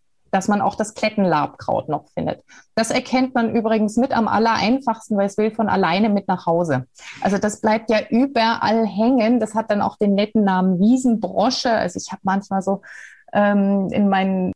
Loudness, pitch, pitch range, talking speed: -19 LUFS, 210 Hz, 195-225 Hz, 180 wpm